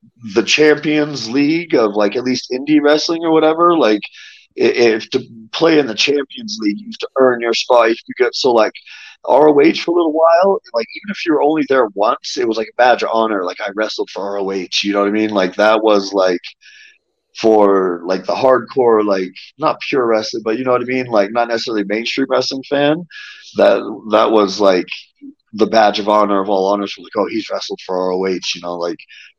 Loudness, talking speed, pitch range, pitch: -15 LUFS, 210 wpm, 105-160 Hz, 125 Hz